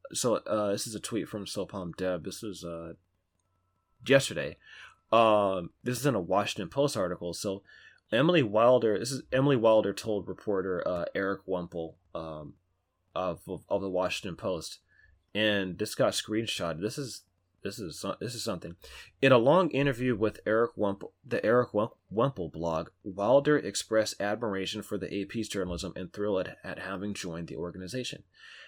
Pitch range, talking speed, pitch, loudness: 90-110 Hz, 160 wpm, 100 Hz, -30 LUFS